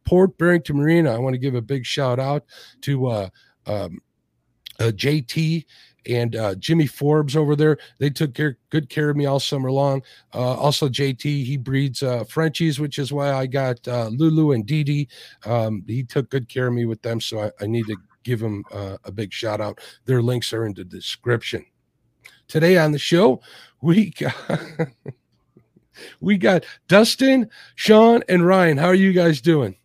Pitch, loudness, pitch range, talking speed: 140 Hz, -20 LUFS, 120-160 Hz, 185 wpm